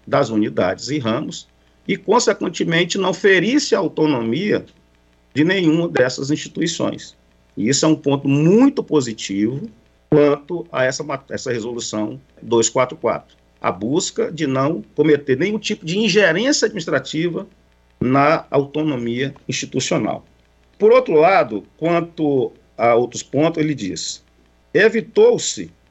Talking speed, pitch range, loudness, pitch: 115 wpm, 115-170 Hz, -18 LUFS, 145 Hz